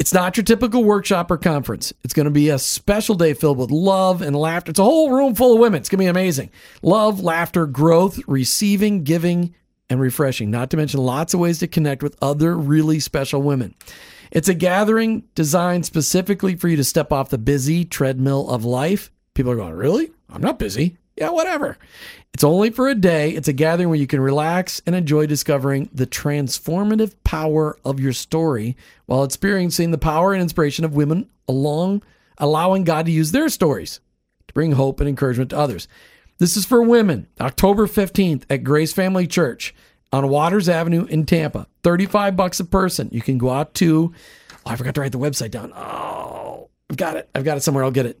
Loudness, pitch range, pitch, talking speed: -18 LUFS, 140-190 Hz, 160 Hz, 200 wpm